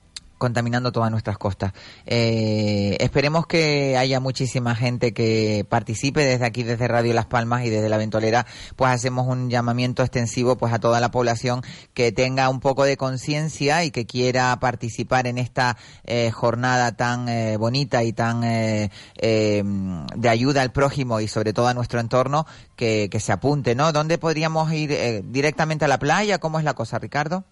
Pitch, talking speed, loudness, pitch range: 125 Hz, 175 wpm, -22 LUFS, 115-135 Hz